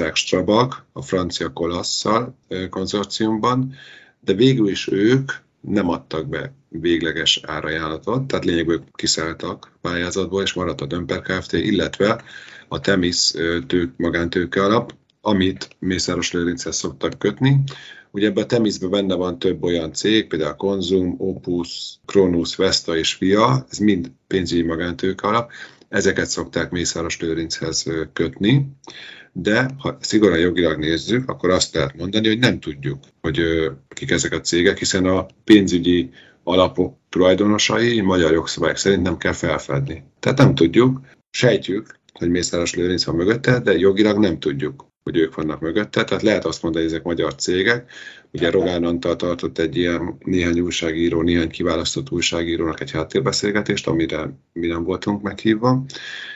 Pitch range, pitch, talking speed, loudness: 85-105 Hz, 90 Hz, 140 wpm, -20 LUFS